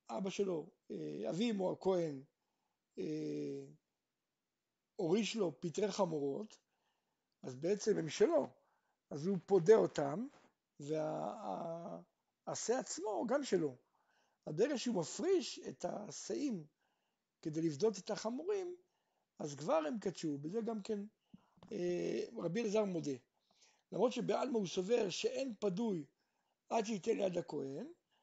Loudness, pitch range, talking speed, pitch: -39 LUFS, 165-230 Hz, 115 wpm, 200 Hz